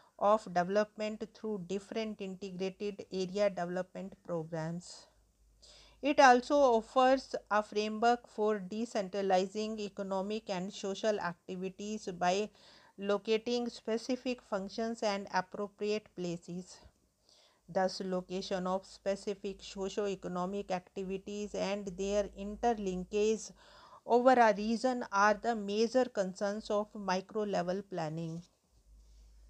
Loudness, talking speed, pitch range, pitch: -34 LUFS, 95 wpm, 190-215 Hz, 205 Hz